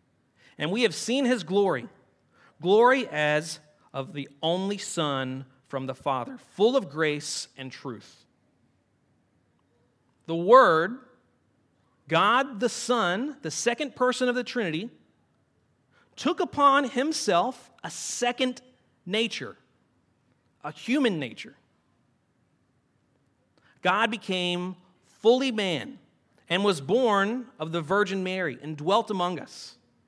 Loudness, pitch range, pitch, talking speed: -26 LUFS, 150-245 Hz, 190 Hz, 110 wpm